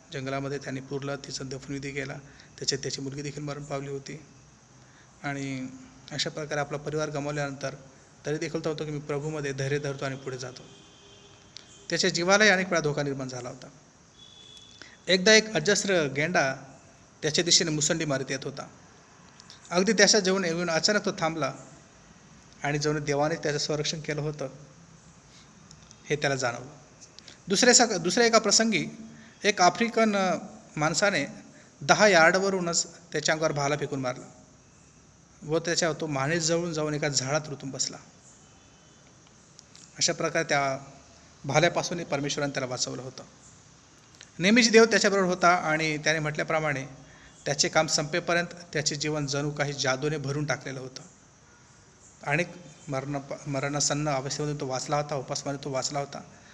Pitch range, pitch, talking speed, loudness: 140-170 Hz, 150 Hz, 135 wpm, -26 LUFS